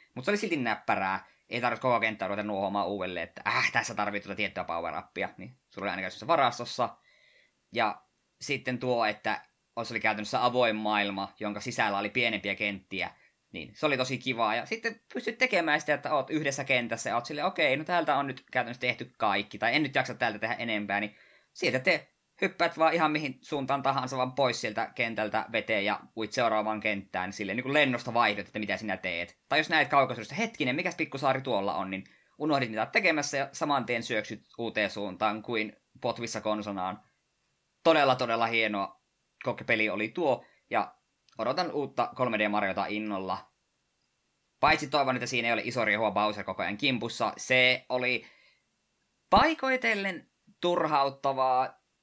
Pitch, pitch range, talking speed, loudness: 120 Hz, 105-140 Hz, 170 wpm, -29 LUFS